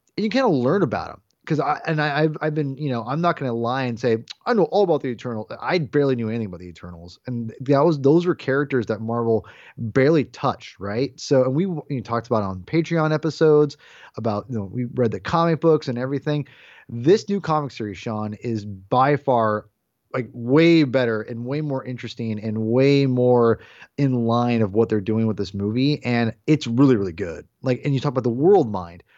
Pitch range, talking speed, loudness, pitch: 110-145 Hz, 215 wpm, -21 LUFS, 125 Hz